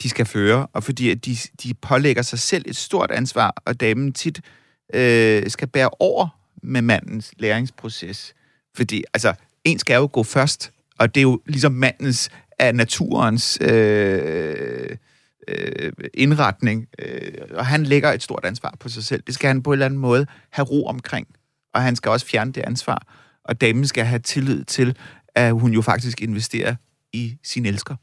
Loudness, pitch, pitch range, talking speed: -20 LUFS, 125 Hz, 115-135 Hz, 180 wpm